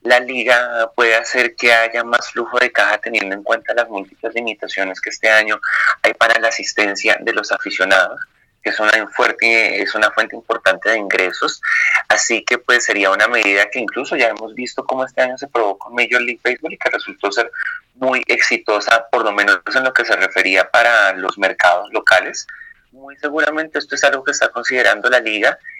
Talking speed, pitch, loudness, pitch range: 195 wpm, 120 Hz, -15 LUFS, 115-140 Hz